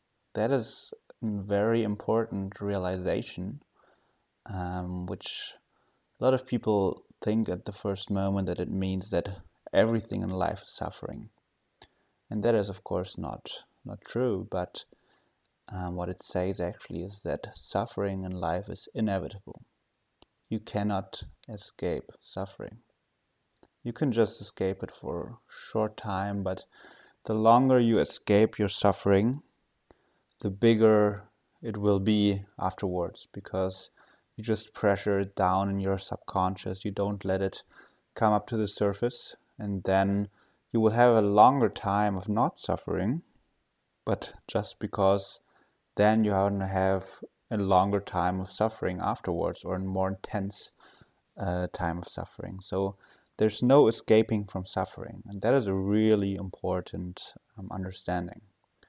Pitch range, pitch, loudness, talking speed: 95-110 Hz, 100 Hz, -29 LUFS, 140 wpm